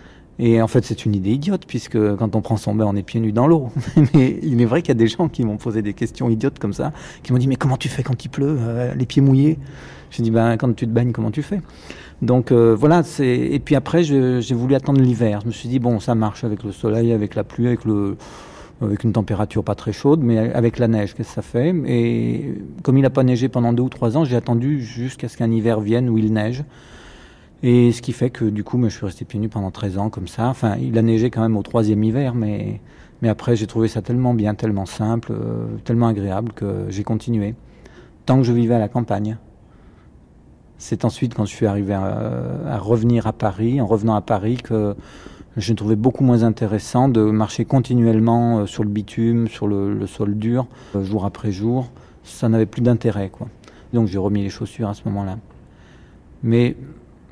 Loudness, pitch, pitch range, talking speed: -19 LUFS, 115 Hz, 105-125 Hz, 230 wpm